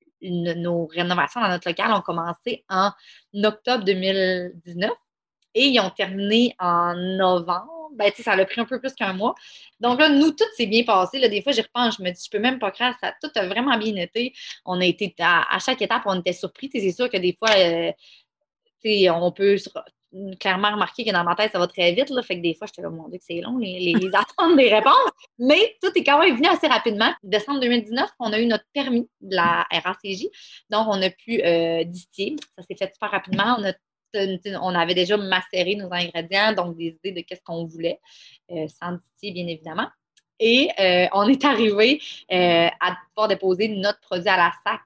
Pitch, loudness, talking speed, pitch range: 200 Hz, -21 LUFS, 215 wpm, 180-240 Hz